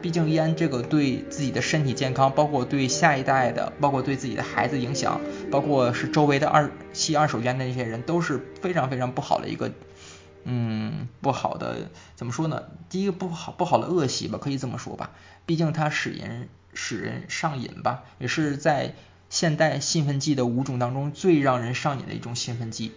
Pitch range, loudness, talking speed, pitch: 125-155 Hz, -25 LUFS, 300 characters per minute, 140 Hz